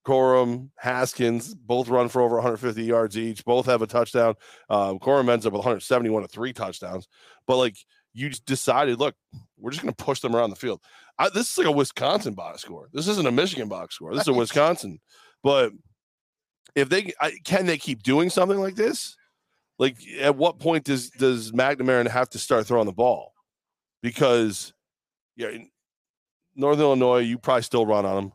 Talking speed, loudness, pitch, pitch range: 190 wpm, -23 LUFS, 125 Hz, 115-135 Hz